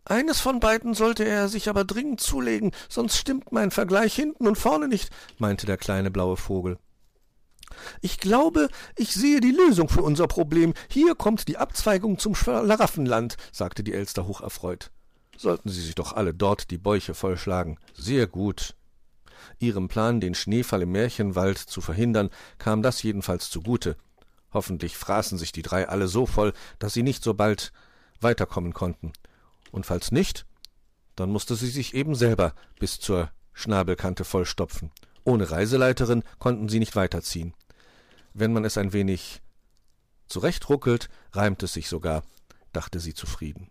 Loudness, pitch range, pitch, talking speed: -25 LUFS, 90-150 Hz, 105 Hz, 150 wpm